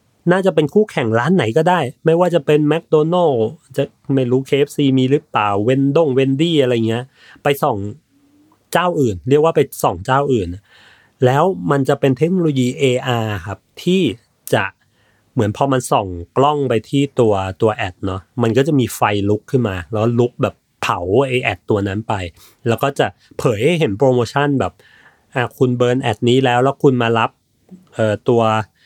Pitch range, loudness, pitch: 110-145 Hz, -17 LUFS, 130 Hz